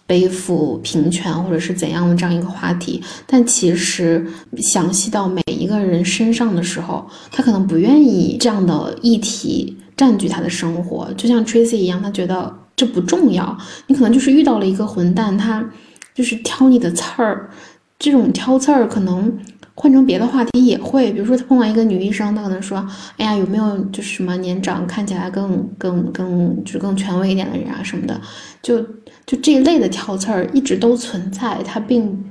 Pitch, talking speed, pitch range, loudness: 200 Hz, 295 characters per minute, 180-240 Hz, -16 LUFS